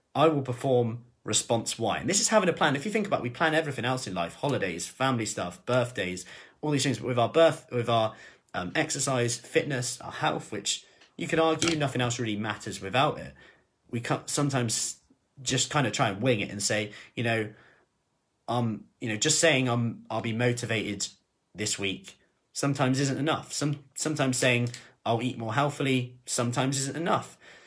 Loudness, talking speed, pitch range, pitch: -28 LUFS, 190 wpm, 115-145 Hz, 125 Hz